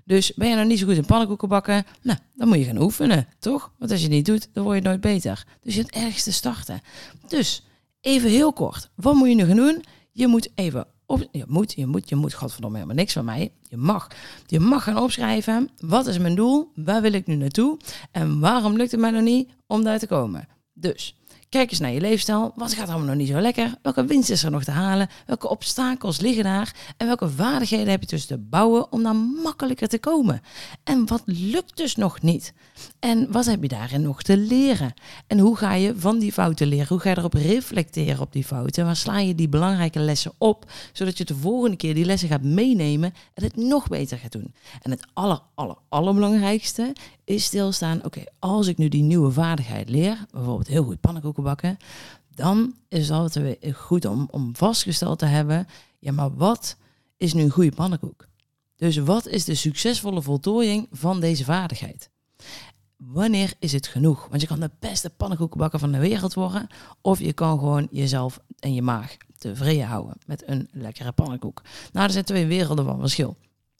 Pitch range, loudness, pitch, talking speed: 145-220 Hz, -22 LUFS, 180 Hz, 210 wpm